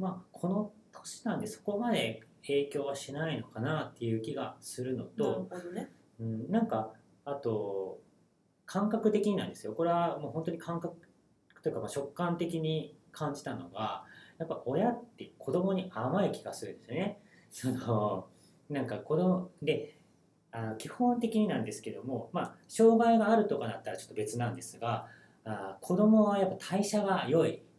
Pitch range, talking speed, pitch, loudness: 130-205 Hz, 290 characters per minute, 165 Hz, -33 LUFS